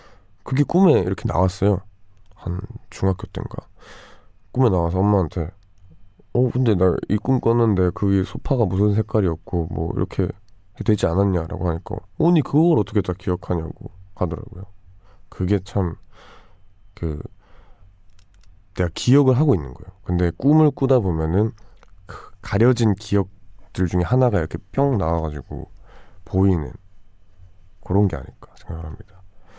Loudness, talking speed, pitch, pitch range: -21 LUFS, 285 characters per minute, 95 Hz, 90-110 Hz